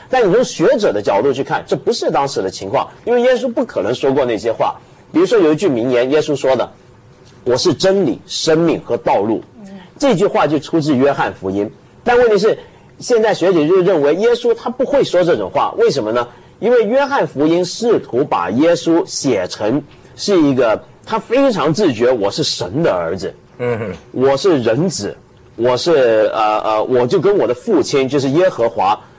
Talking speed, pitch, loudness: 275 characters per minute, 185 Hz, -15 LUFS